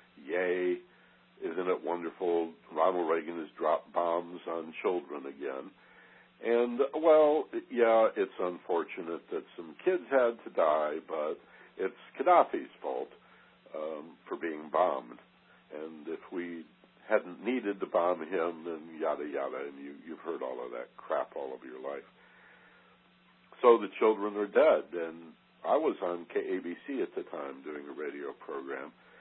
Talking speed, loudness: 145 wpm, -32 LUFS